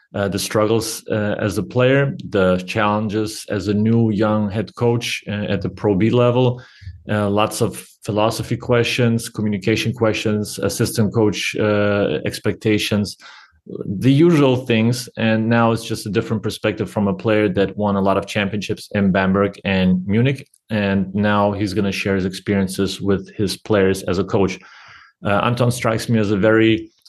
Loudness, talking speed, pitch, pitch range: -19 LUFS, 170 wpm, 105 Hz, 100-115 Hz